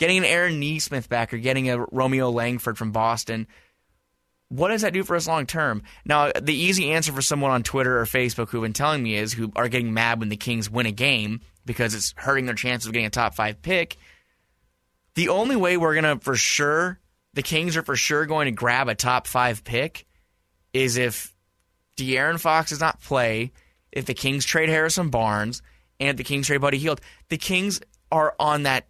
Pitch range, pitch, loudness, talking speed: 115-150 Hz, 130 Hz, -23 LUFS, 210 wpm